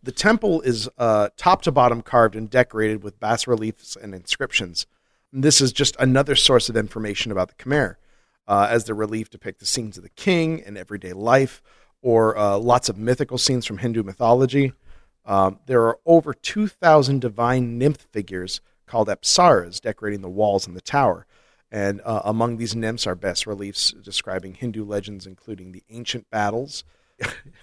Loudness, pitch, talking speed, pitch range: -21 LUFS, 115 Hz, 170 wpm, 100-125 Hz